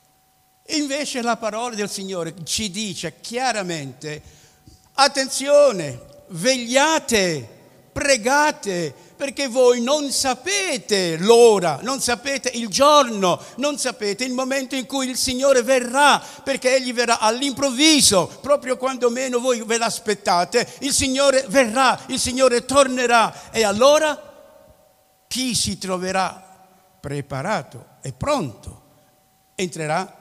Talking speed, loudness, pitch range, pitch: 105 wpm, -19 LUFS, 190-275 Hz, 245 Hz